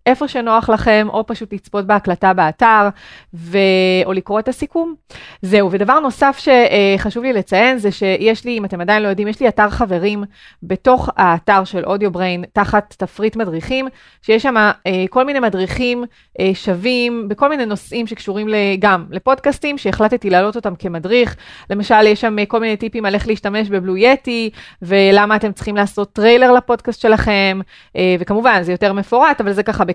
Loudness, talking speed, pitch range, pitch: -15 LUFS, 150 wpm, 195-235 Hz, 210 Hz